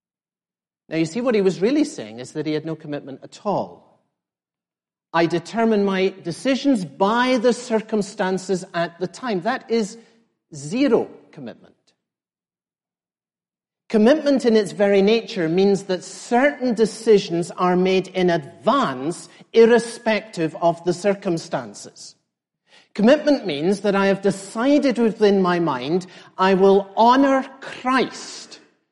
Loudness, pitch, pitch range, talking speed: -20 LUFS, 200 Hz, 180-230 Hz, 125 wpm